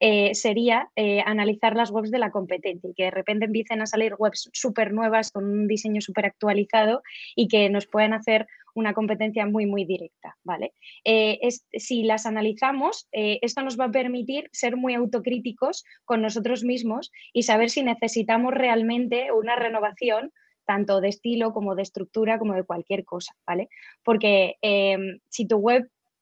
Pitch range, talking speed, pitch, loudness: 210-240 Hz, 170 wpm, 220 Hz, -24 LUFS